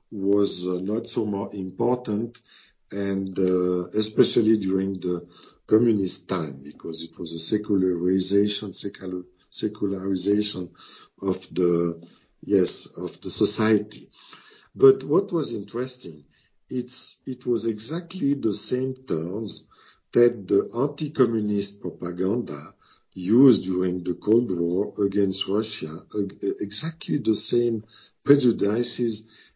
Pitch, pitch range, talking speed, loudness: 105 Hz, 95-120 Hz, 105 wpm, -25 LUFS